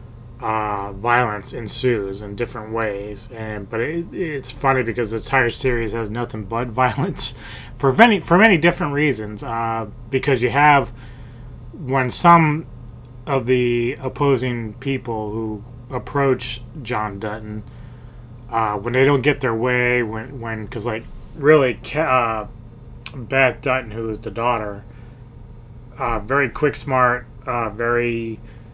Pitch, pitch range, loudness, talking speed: 120 Hz, 115-130 Hz, -20 LUFS, 135 wpm